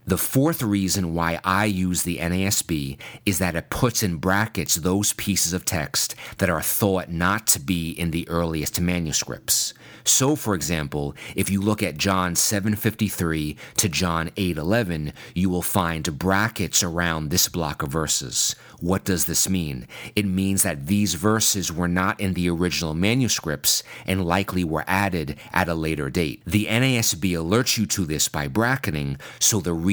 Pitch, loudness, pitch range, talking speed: 95 Hz, -22 LUFS, 85-105 Hz, 165 wpm